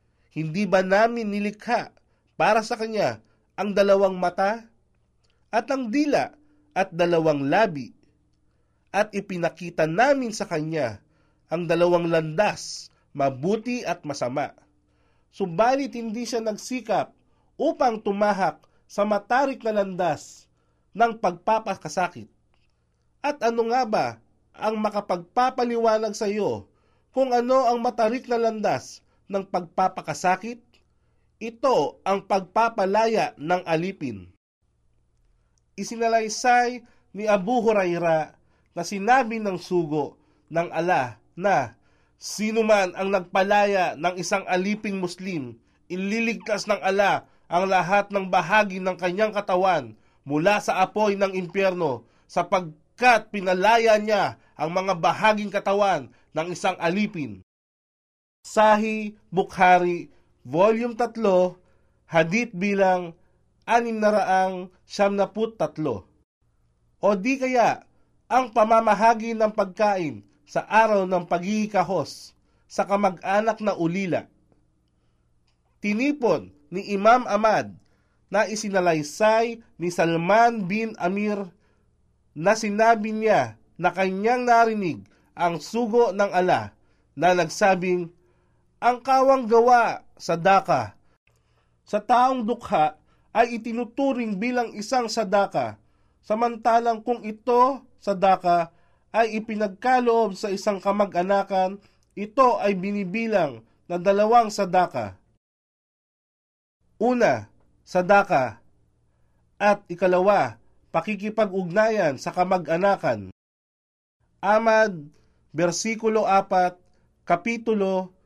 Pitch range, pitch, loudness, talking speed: 175-220 Hz, 200 Hz, -23 LUFS, 95 wpm